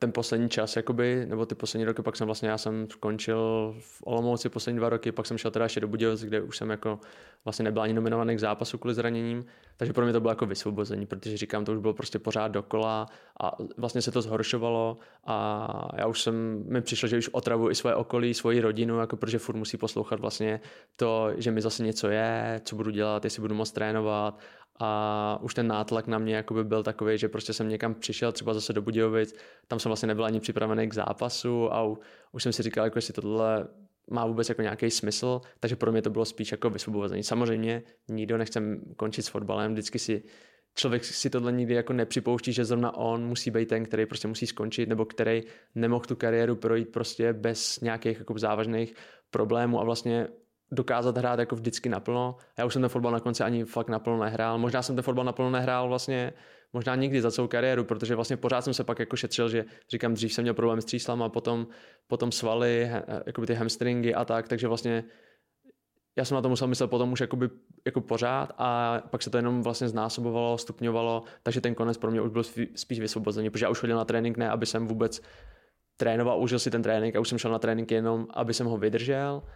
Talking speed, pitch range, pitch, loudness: 215 wpm, 110-120 Hz, 115 Hz, -29 LUFS